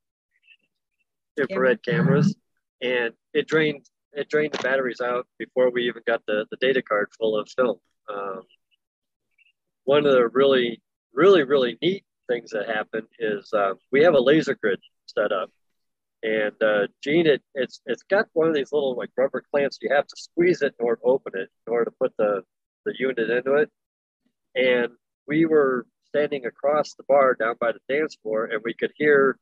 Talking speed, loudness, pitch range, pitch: 180 wpm, -23 LUFS, 120-160 Hz, 135 Hz